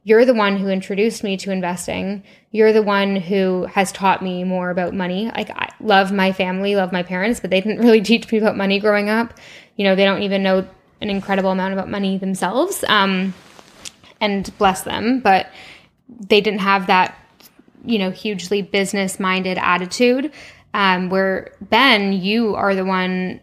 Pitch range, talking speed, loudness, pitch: 190-215 Hz, 180 wpm, -18 LUFS, 195 Hz